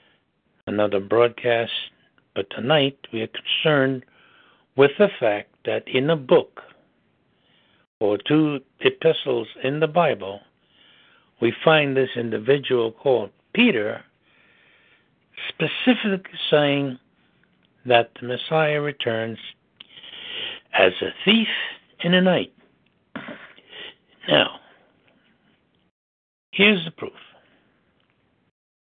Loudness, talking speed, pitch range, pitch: -21 LUFS, 85 wpm, 115-175 Hz, 140 Hz